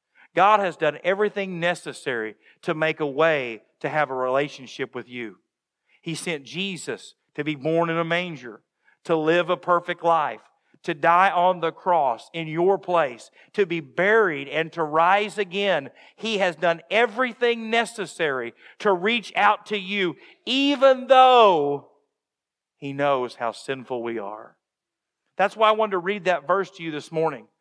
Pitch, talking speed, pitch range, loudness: 170 Hz, 160 wpm, 155-200 Hz, -22 LUFS